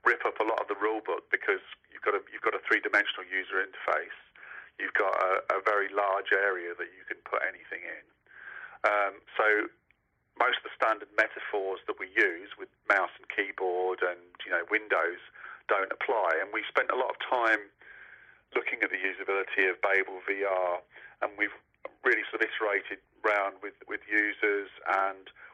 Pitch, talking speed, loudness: 100 Hz, 180 wpm, -29 LUFS